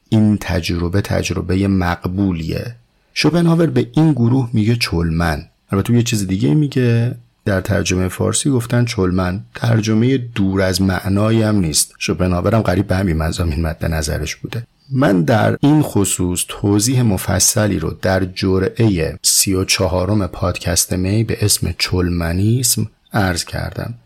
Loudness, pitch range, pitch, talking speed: -16 LUFS, 90-115 Hz, 100 Hz, 125 wpm